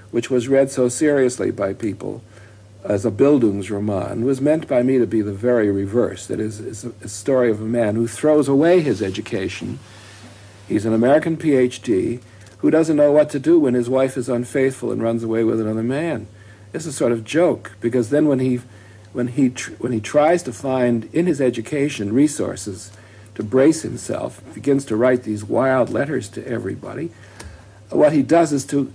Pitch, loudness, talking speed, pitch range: 120 Hz, -19 LUFS, 190 wpm, 105-135 Hz